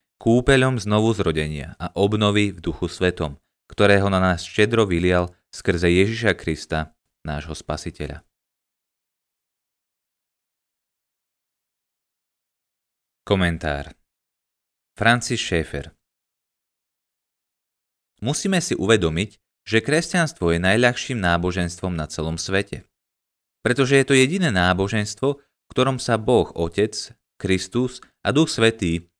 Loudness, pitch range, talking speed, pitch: -21 LUFS, 85-115 Hz, 95 wpm, 95 Hz